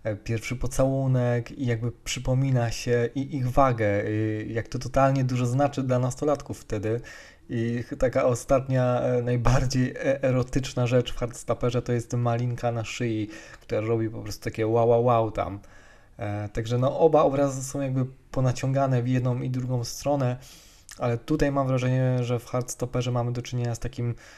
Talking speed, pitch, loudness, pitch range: 160 wpm, 125 Hz, -26 LUFS, 115-130 Hz